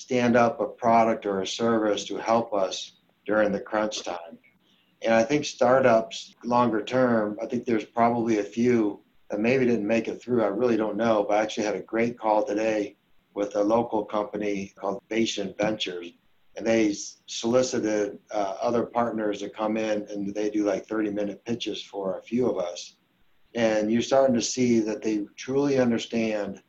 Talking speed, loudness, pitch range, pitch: 180 wpm, -26 LUFS, 105-115 Hz, 110 Hz